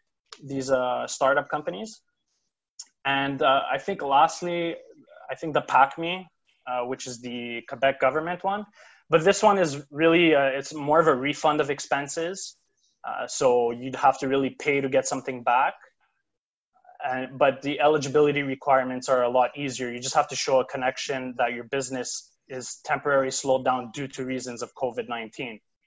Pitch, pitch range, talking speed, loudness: 140 Hz, 130-155 Hz, 165 wpm, -25 LUFS